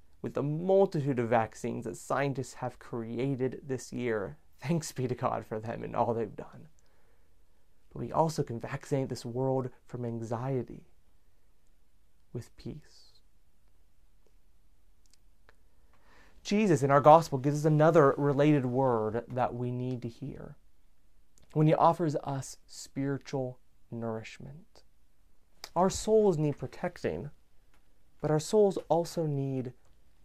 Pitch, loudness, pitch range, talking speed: 125 Hz, -30 LUFS, 95-145 Hz, 120 wpm